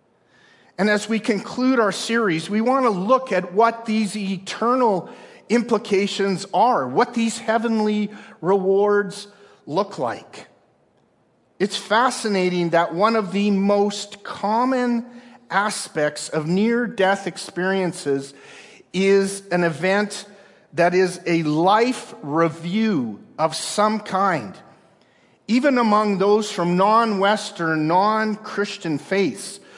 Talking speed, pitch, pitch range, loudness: 110 wpm, 205 Hz, 185-220 Hz, -21 LUFS